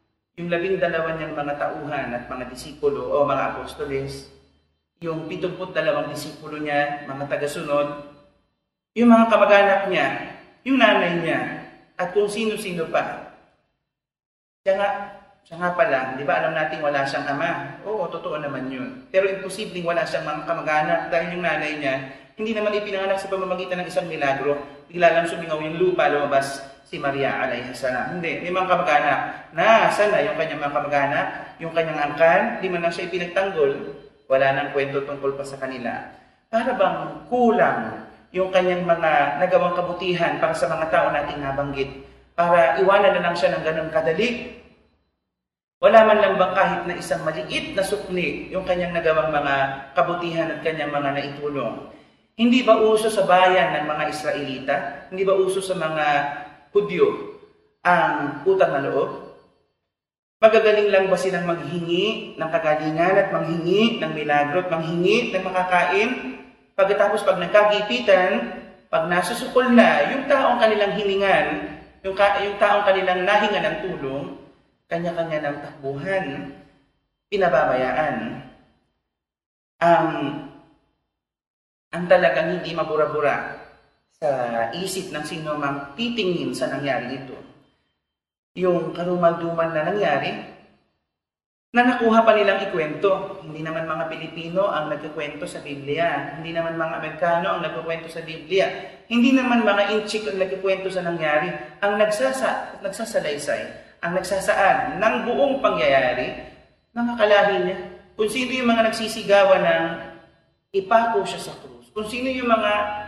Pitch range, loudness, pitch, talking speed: 150-200 Hz, -21 LUFS, 175 Hz, 140 wpm